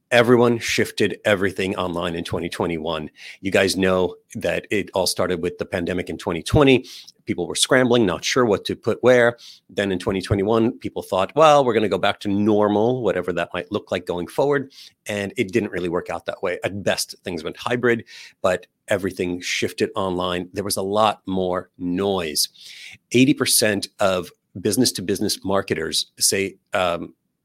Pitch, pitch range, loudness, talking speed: 100 Hz, 90-120 Hz, -21 LUFS, 170 wpm